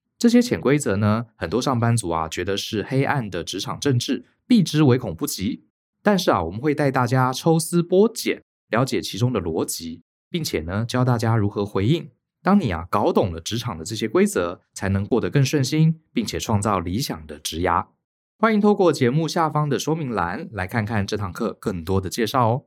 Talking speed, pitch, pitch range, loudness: 295 characters per minute, 125 Hz, 105-160 Hz, -22 LUFS